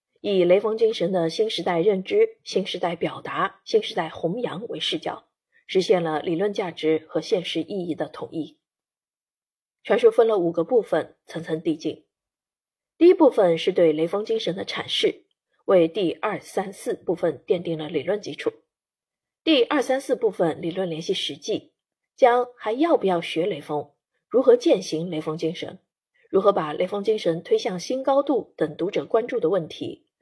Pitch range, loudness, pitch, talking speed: 165-255 Hz, -23 LUFS, 190 Hz, 250 characters per minute